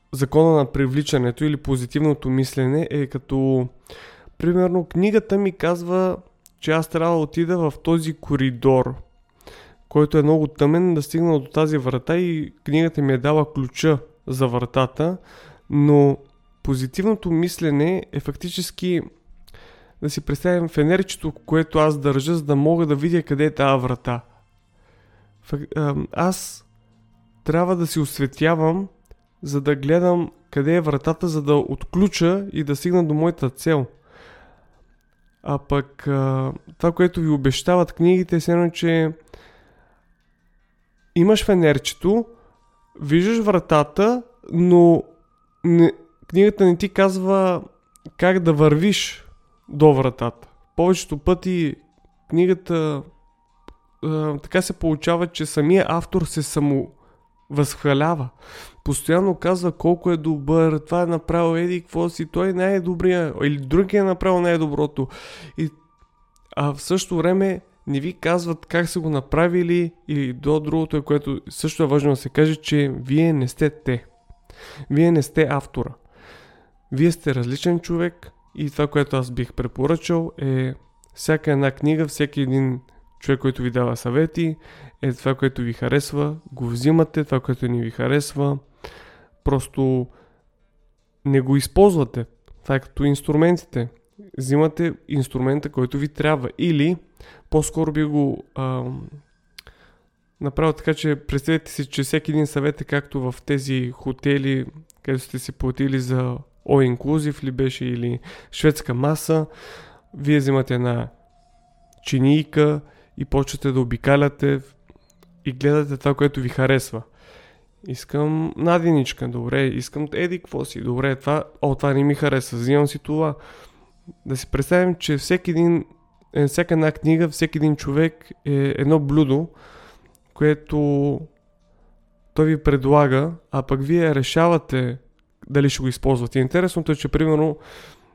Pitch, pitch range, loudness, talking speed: 150 Hz, 135-165 Hz, -21 LUFS, 130 wpm